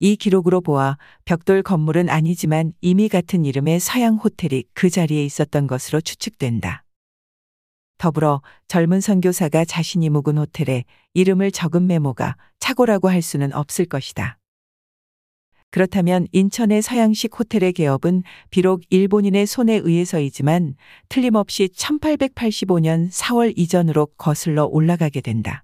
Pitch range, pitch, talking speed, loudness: 150-195 Hz, 170 Hz, 300 characters per minute, -19 LUFS